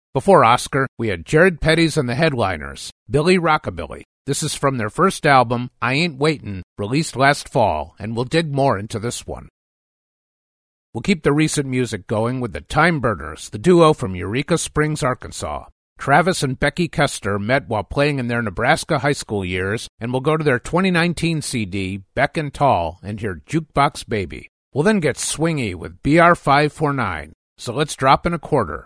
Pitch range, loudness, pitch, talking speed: 105-155 Hz, -19 LUFS, 135 Hz, 185 wpm